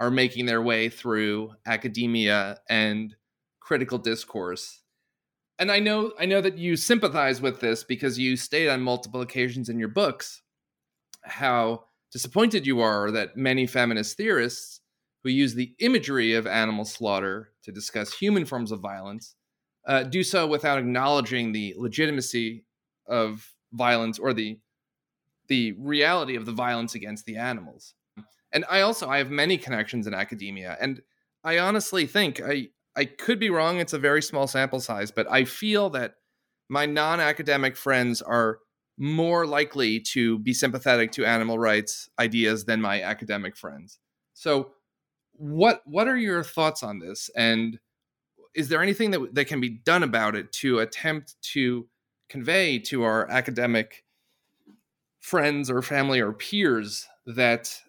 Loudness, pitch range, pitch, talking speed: -25 LUFS, 115-150 Hz, 125 Hz, 150 wpm